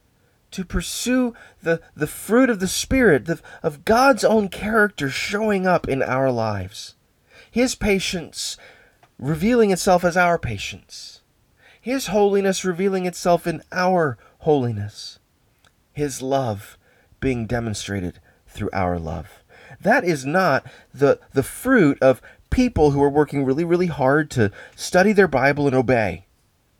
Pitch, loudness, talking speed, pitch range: 150 Hz, -20 LUFS, 130 wpm, 120-190 Hz